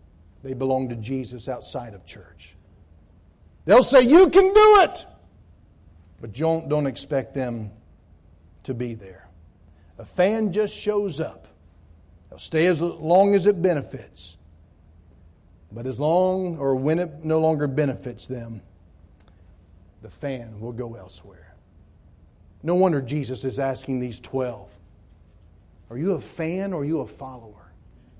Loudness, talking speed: -22 LUFS, 135 wpm